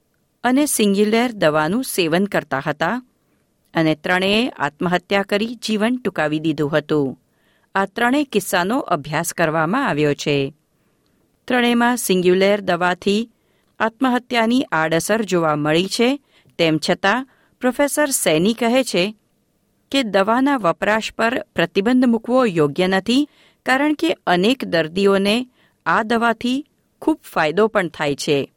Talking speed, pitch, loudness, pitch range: 115 wpm, 205 Hz, -19 LUFS, 165-245 Hz